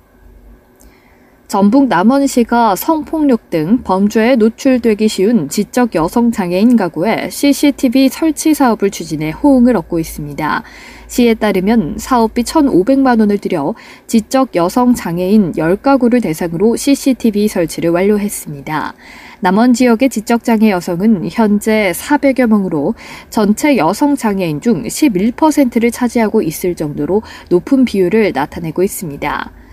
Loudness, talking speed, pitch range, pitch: -13 LUFS, 280 characters per minute, 190-255 Hz, 225 Hz